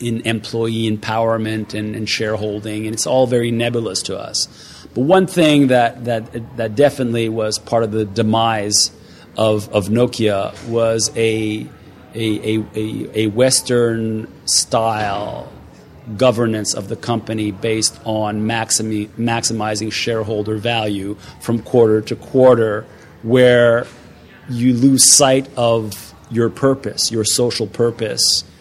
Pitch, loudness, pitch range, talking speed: 115 Hz, -16 LUFS, 110-120 Hz, 125 wpm